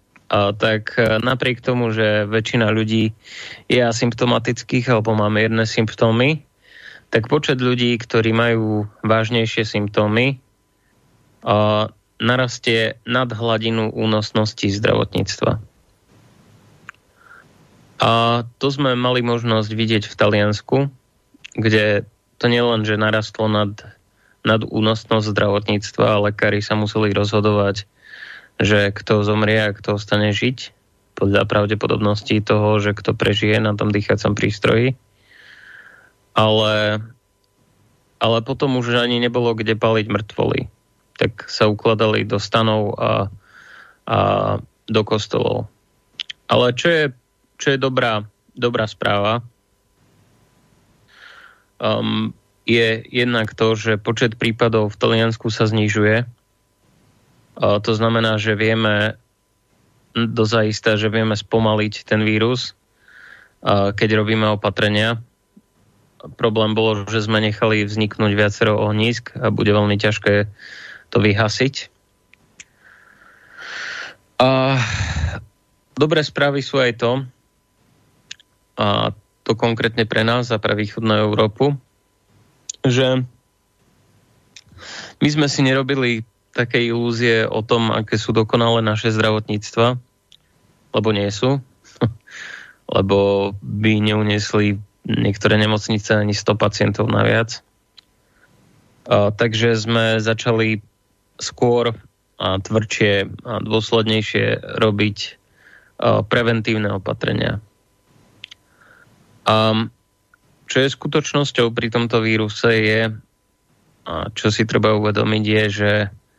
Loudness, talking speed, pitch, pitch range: -18 LUFS, 100 wpm, 110 Hz, 105-120 Hz